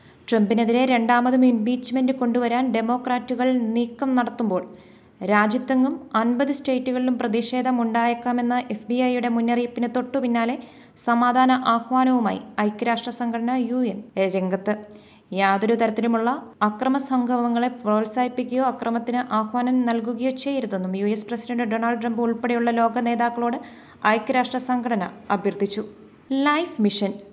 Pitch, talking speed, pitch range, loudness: 240 Hz, 95 wpm, 225-250 Hz, -22 LUFS